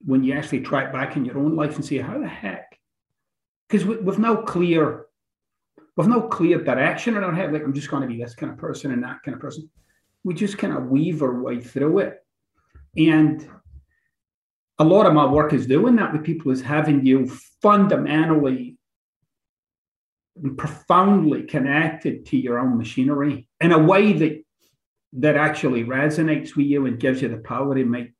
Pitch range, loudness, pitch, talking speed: 130-160 Hz, -20 LUFS, 150 Hz, 190 wpm